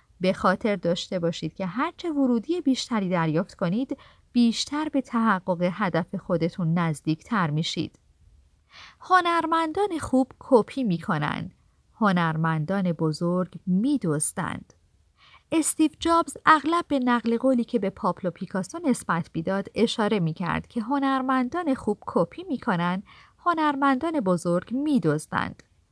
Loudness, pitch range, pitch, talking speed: -25 LUFS, 175-275 Hz, 220 Hz, 115 wpm